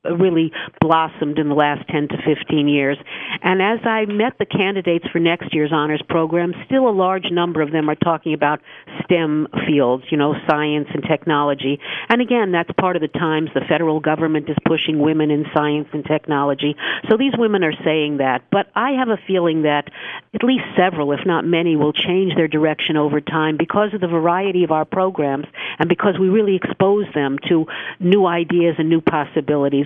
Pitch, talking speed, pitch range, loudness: 160 Hz, 195 wpm, 150-185 Hz, -18 LUFS